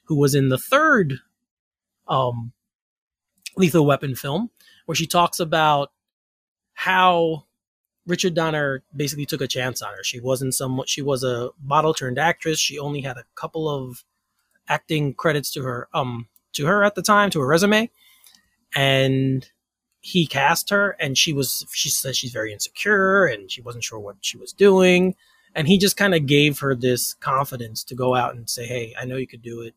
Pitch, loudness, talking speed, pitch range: 145 Hz, -21 LUFS, 185 wpm, 130-170 Hz